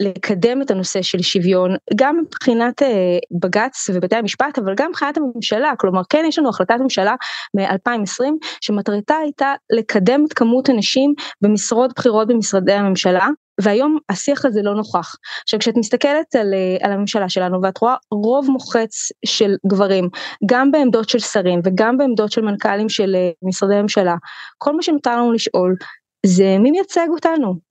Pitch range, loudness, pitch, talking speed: 195-265 Hz, -17 LUFS, 220 Hz, 150 wpm